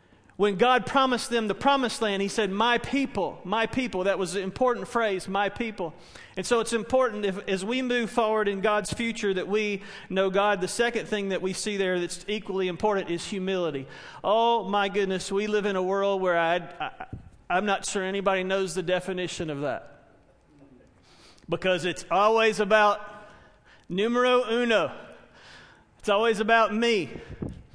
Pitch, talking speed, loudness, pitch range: 200 Hz, 170 wpm, -26 LUFS, 190-225 Hz